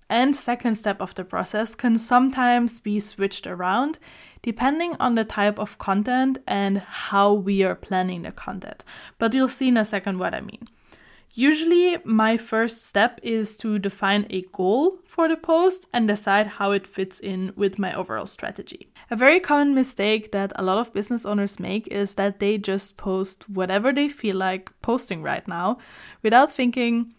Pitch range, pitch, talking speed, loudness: 200-245 Hz, 215 Hz, 175 wpm, -22 LUFS